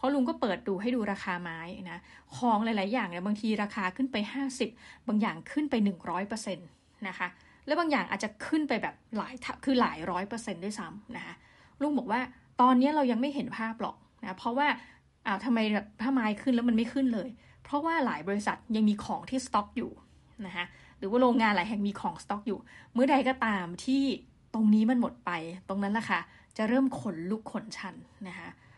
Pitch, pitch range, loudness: 225 Hz, 200-255 Hz, -30 LUFS